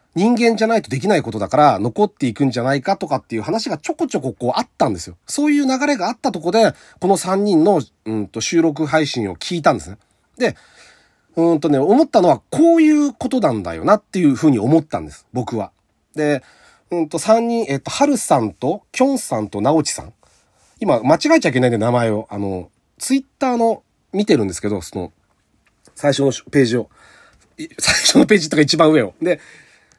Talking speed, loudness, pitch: 390 characters per minute, -17 LUFS, 160 Hz